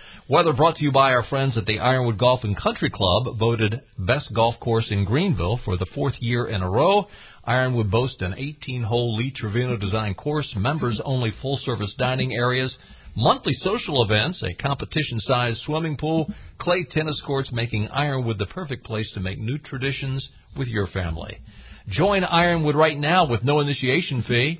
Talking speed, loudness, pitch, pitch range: 180 wpm, -22 LUFS, 125 Hz, 110-145 Hz